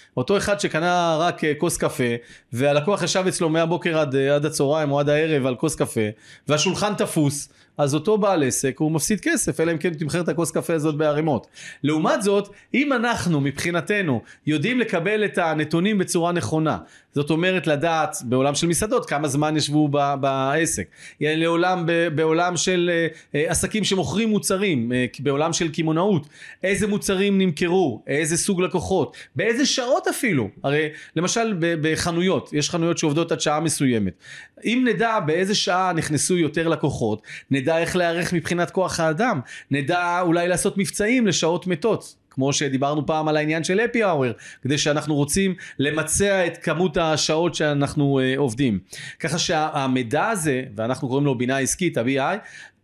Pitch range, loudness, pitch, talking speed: 145-185 Hz, -22 LUFS, 165 Hz, 150 wpm